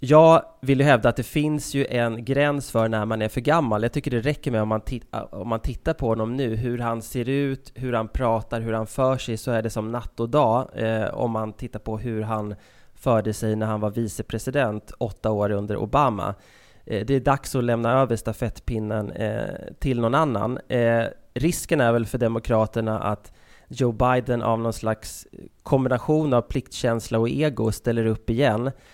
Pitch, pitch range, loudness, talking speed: 115 Hz, 110-130 Hz, -24 LUFS, 200 wpm